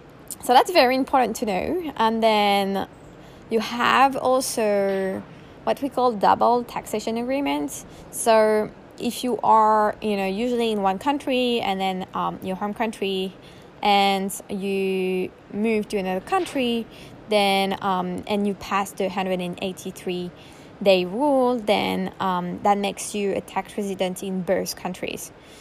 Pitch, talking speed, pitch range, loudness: 205 Hz, 140 wpm, 190-235 Hz, -23 LUFS